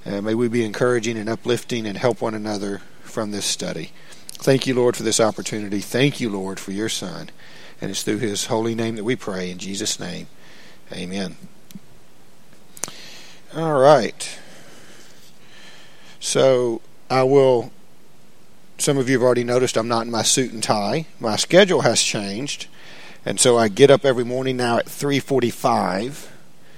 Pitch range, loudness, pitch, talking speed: 105-130 Hz, -20 LUFS, 120 Hz, 160 wpm